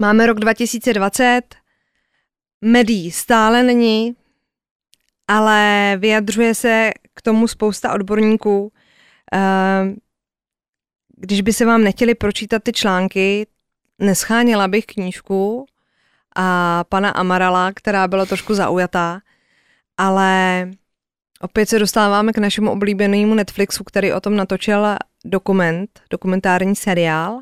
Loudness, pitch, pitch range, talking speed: -16 LUFS, 205 Hz, 190-225 Hz, 100 wpm